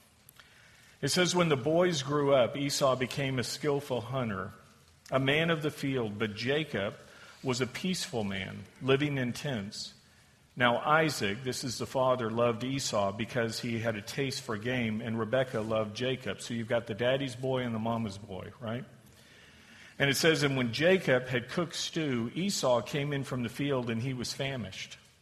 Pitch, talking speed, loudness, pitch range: 130 Hz, 180 wpm, -31 LUFS, 115-140 Hz